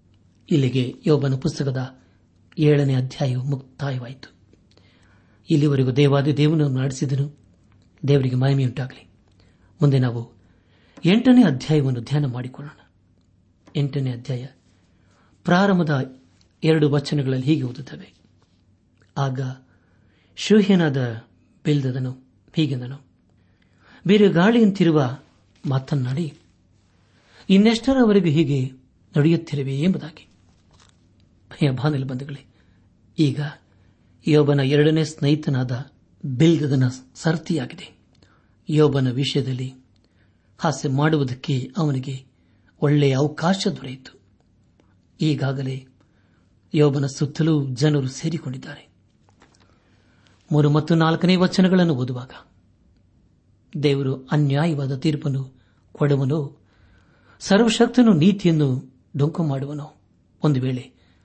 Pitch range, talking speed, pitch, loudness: 100-150 Hz, 70 wpm, 135 Hz, -21 LUFS